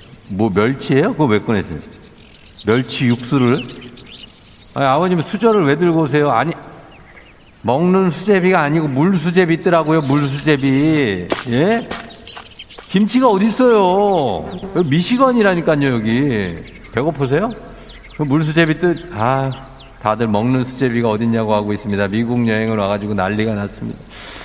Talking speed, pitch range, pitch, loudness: 290 characters per minute, 115-175 Hz, 140 Hz, -16 LUFS